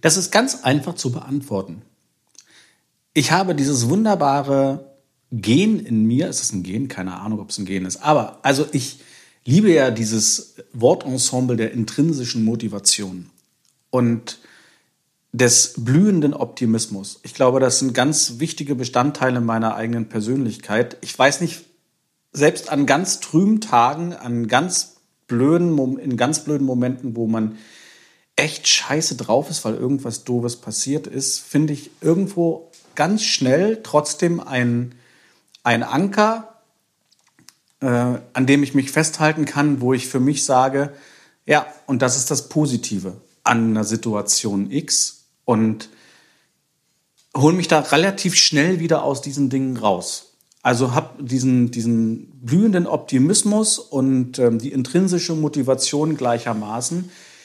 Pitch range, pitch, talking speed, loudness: 120-155 Hz, 135 Hz, 135 wpm, -19 LUFS